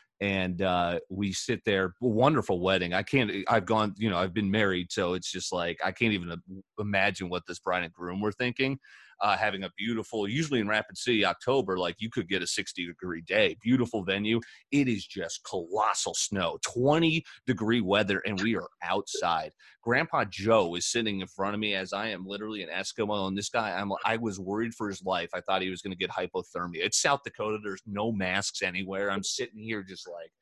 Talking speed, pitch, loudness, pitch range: 205 wpm, 100 Hz, -29 LUFS, 95-110 Hz